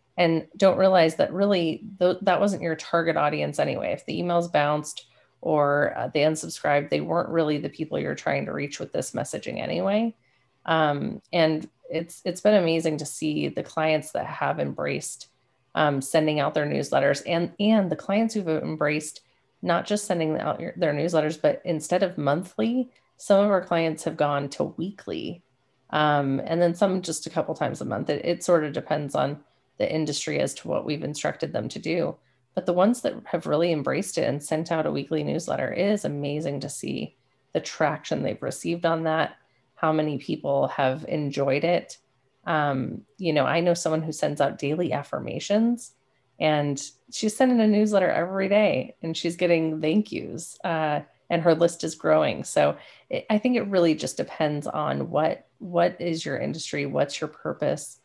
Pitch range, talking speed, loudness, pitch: 145-180 Hz, 185 wpm, -25 LUFS, 160 Hz